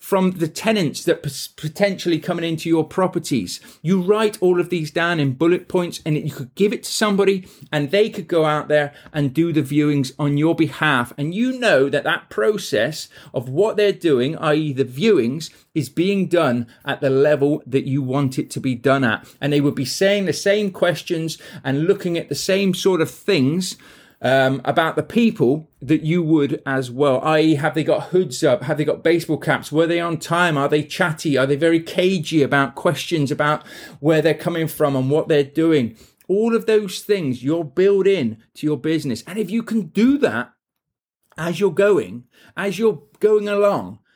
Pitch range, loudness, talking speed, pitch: 145-185 Hz, -19 LUFS, 200 wpm, 160 Hz